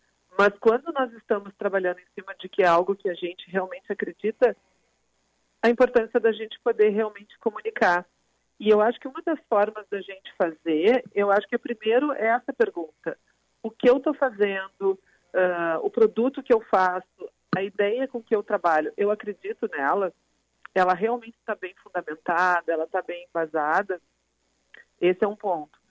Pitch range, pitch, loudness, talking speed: 185-230 Hz, 205 Hz, -25 LUFS, 175 wpm